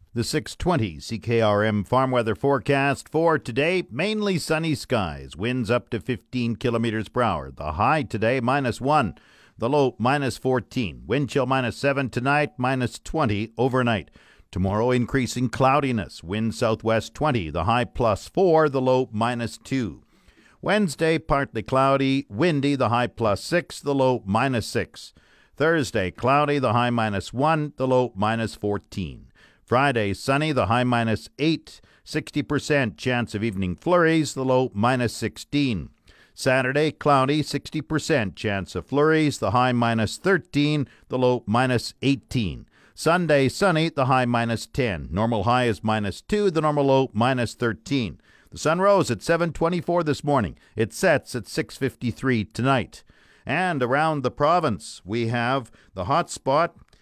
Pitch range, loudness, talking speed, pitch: 110-145 Hz, -23 LUFS, 145 wpm, 125 Hz